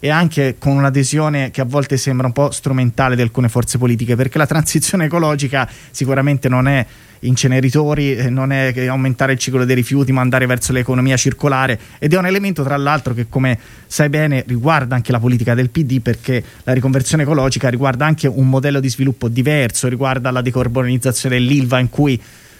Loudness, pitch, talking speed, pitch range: -15 LUFS, 130 Hz, 180 wpm, 125-140 Hz